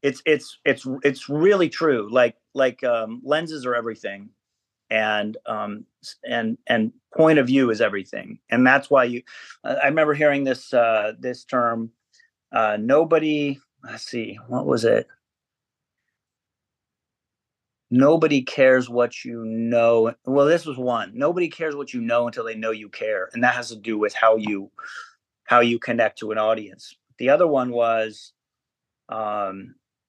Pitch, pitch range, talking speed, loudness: 125 Hz, 115-150 Hz, 155 wpm, -21 LUFS